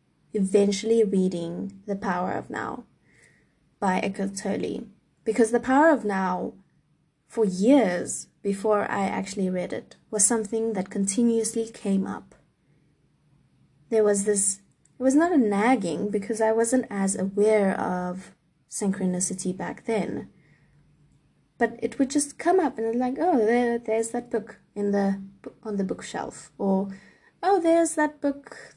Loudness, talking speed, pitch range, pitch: -25 LUFS, 140 wpm, 195-235 Hz, 210 Hz